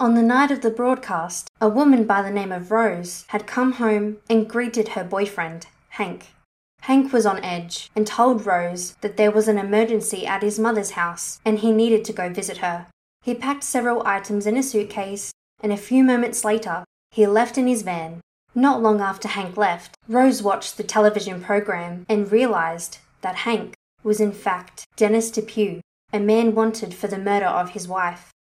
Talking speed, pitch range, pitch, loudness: 185 wpm, 185-225 Hz, 210 Hz, -21 LUFS